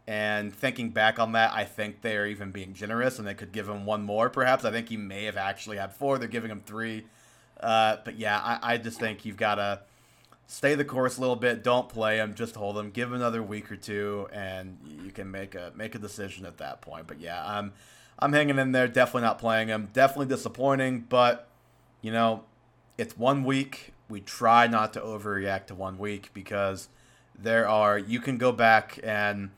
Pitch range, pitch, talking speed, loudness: 105-120 Hz, 110 Hz, 215 wpm, -27 LUFS